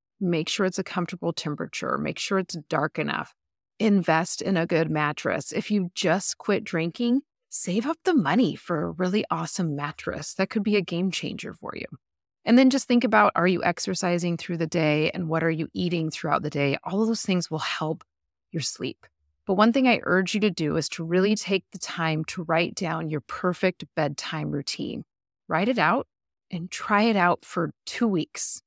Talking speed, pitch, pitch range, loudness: 200 wpm, 175 Hz, 160-205 Hz, -25 LUFS